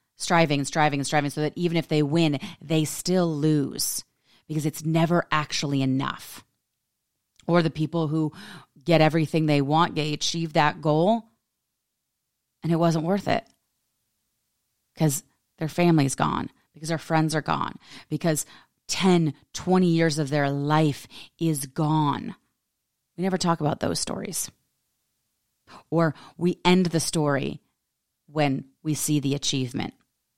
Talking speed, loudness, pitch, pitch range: 140 wpm, -25 LUFS, 155 Hz, 150-165 Hz